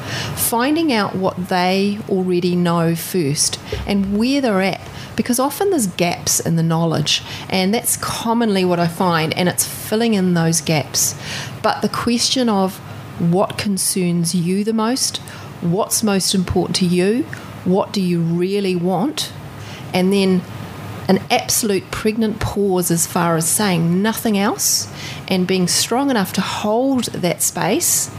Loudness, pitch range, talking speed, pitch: -18 LUFS, 165-210 Hz, 145 wpm, 185 Hz